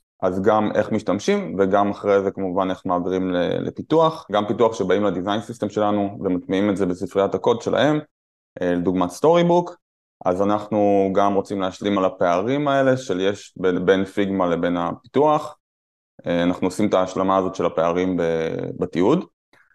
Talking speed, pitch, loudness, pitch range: 150 wpm, 95 Hz, -21 LUFS, 90-105 Hz